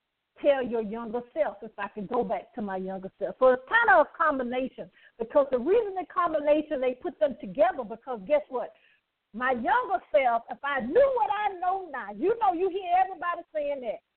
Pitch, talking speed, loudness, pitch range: 295 Hz, 205 wpm, -27 LUFS, 245-365 Hz